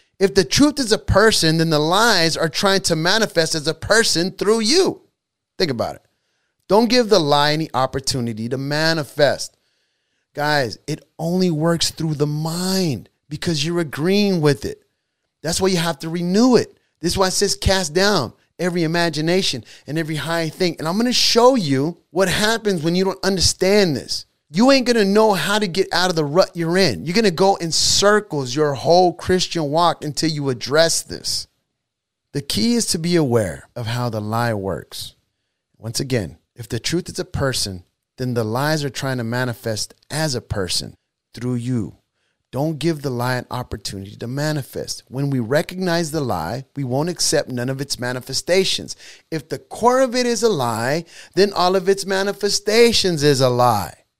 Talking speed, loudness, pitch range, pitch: 185 wpm, -19 LUFS, 130-190 Hz, 160 Hz